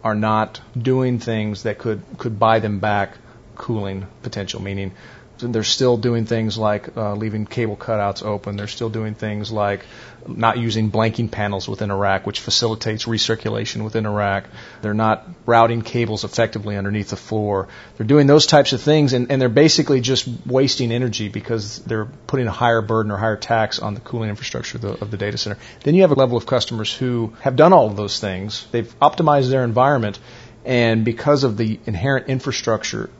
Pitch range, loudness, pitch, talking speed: 105-125 Hz, -19 LUFS, 115 Hz, 185 wpm